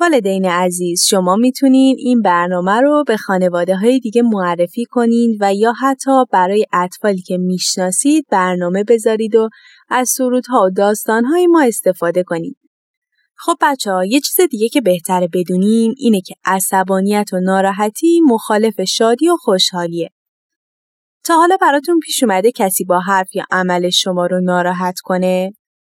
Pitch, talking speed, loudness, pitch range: 210 Hz, 145 wpm, -14 LUFS, 185-250 Hz